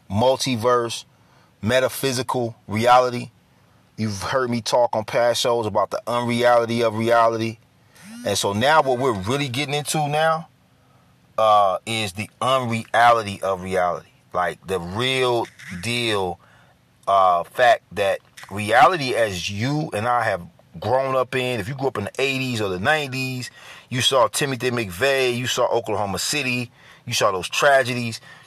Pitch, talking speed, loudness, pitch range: 120 Hz, 145 wpm, -21 LUFS, 110-130 Hz